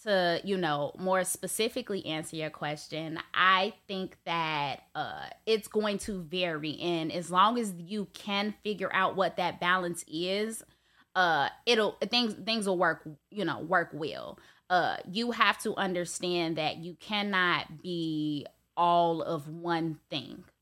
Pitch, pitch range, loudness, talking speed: 180 Hz, 165-200 Hz, -30 LUFS, 150 wpm